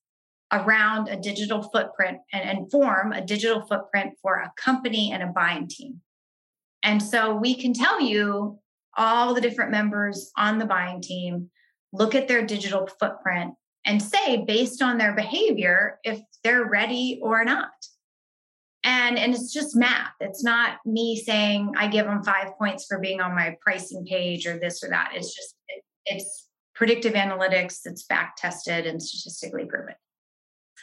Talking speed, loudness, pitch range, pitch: 160 wpm, -24 LUFS, 195-235 Hz, 210 Hz